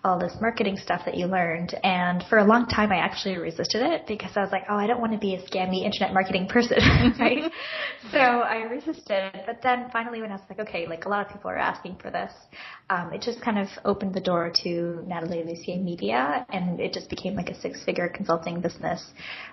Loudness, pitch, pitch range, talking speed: -26 LUFS, 195 Hz, 180-230 Hz, 225 wpm